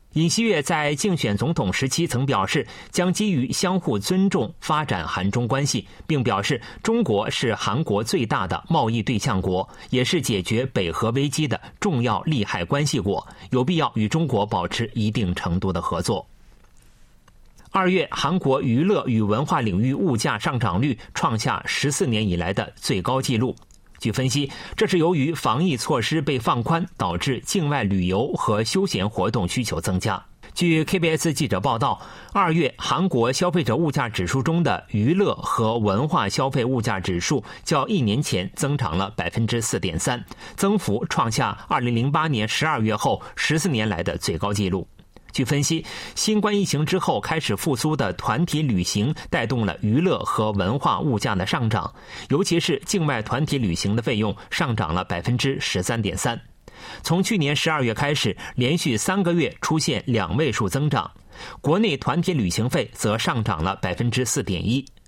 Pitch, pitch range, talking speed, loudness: 130 Hz, 105-160 Hz, 265 characters per minute, -23 LUFS